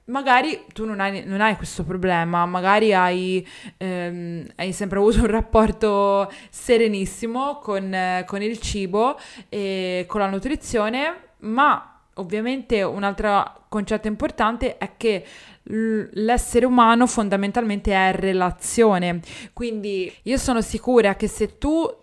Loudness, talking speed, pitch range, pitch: -21 LUFS, 125 wpm, 195-230 Hz, 215 Hz